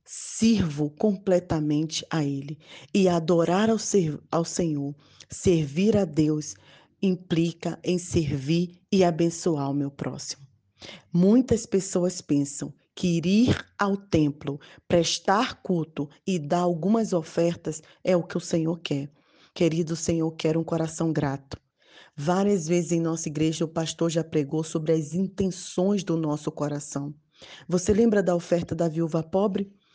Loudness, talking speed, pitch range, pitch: -26 LUFS, 135 wpm, 155-185 Hz, 170 Hz